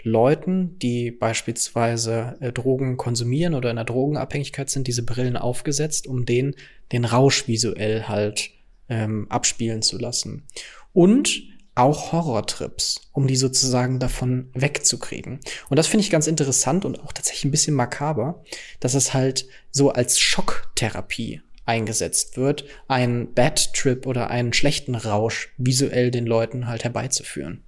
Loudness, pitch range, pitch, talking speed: -22 LUFS, 115-140 Hz, 125 Hz, 135 wpm